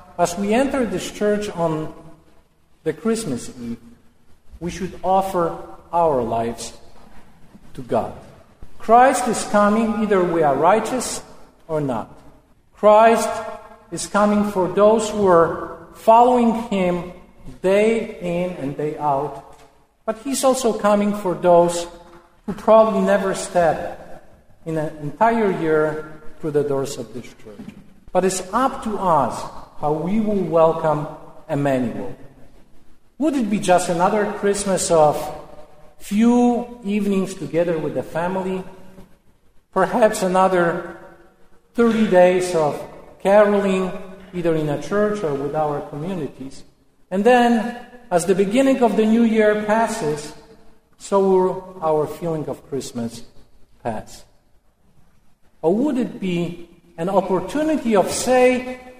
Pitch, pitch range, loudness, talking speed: 185 Hz, 155-215 Hz, -19 LUFS, 125 wpm